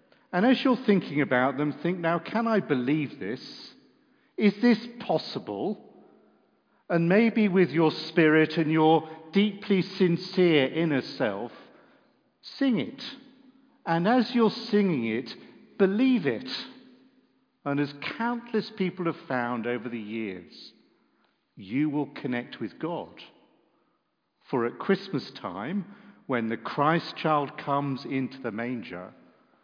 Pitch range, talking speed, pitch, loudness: 145-225 Hz, 125 wpm, 170 Hz, -27 LUFS